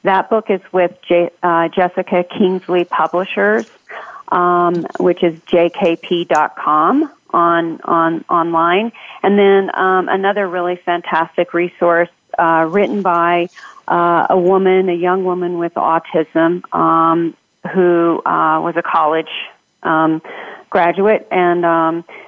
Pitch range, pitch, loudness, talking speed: 165-185 Hz, 175 Hz, -15 LUFS, 120 wpm